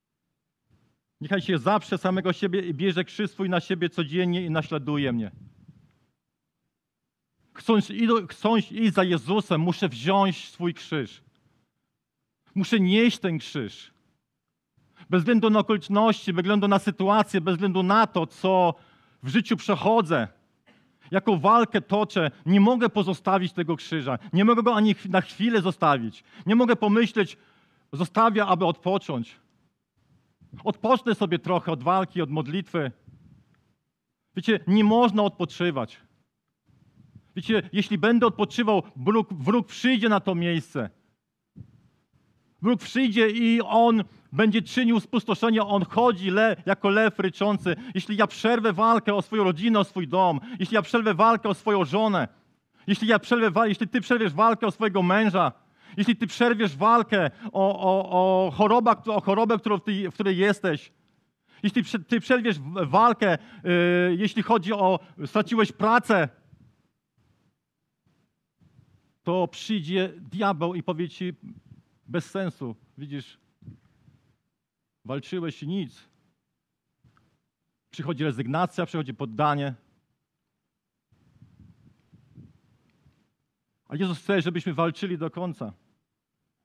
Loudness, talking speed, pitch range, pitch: -24 LUFS, 120 wpm, 175-220 Hz, 195 Hz